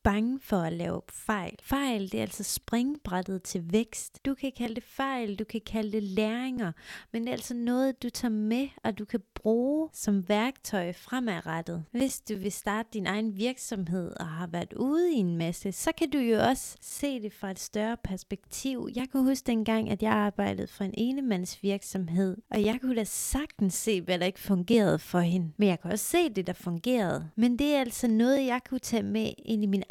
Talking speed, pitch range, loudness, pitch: 210 wpm, 195-250 Hz, -30 LUFS, 220 Hz